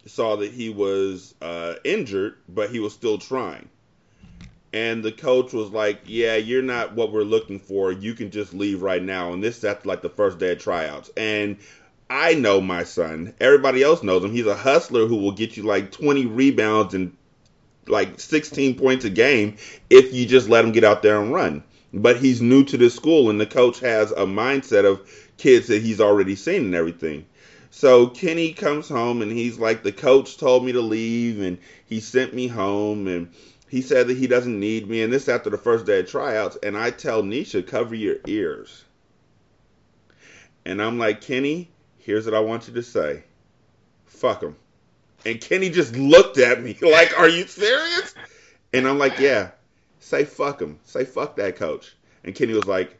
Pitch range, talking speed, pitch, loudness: 105-135 Hz, 195 wpm, 115 Hz, -20 LUFS